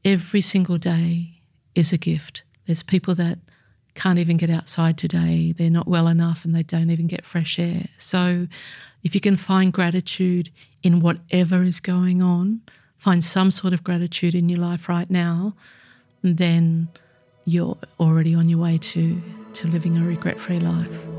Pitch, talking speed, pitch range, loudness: 170 Hz, 165 wpm, 165-180 Hz, -21 LUFS